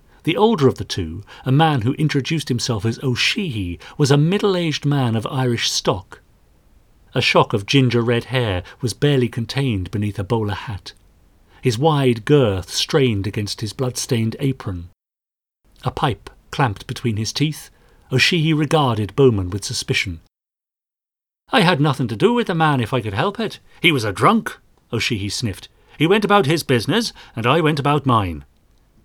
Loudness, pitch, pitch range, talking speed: -19 LUFS, 125 Hz, 105-145 Hz, 165 wpm